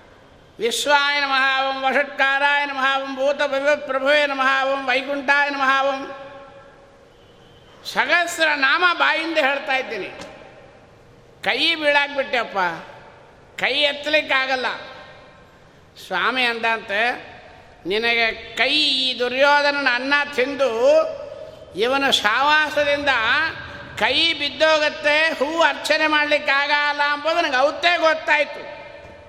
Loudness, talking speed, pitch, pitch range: -18 LUFS, 75 wpm, 285 Hz, 270-300 Hz